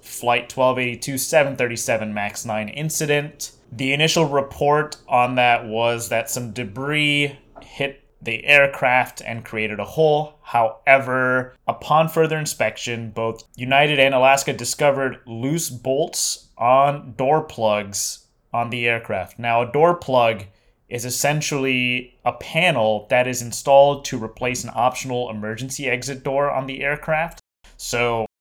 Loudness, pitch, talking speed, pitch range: -20 LUFS, 125 Hz, 130 wpm, 115-140 Hz